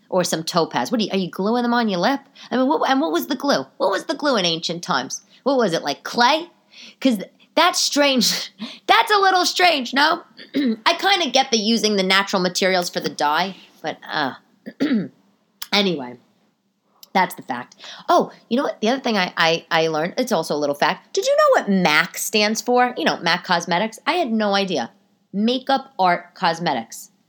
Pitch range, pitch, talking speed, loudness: 180-270 Hz, 215 Hz, 205 wpm, -19 LUFS